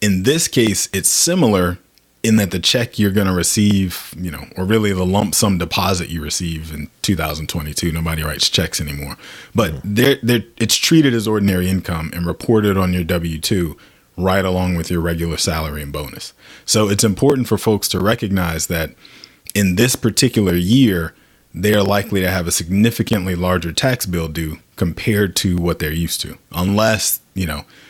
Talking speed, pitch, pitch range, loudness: 175 wpm, 95 Hz, 85-105 Hz, -17 LUFS